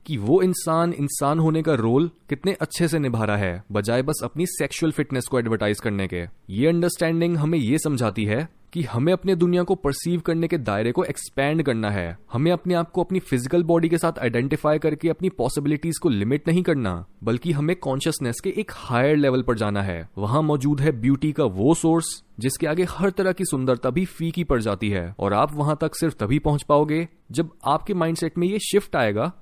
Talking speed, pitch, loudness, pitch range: 205 wpm, 150 Hz, -23 LUFS, 120-170 Hz